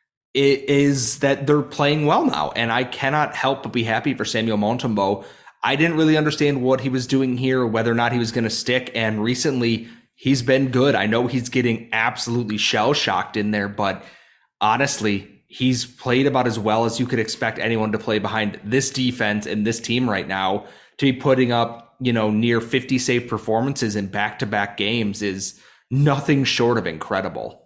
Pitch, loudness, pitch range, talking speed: 120 Hz, -21 LUFS, 110-135 Hz, 190 wpm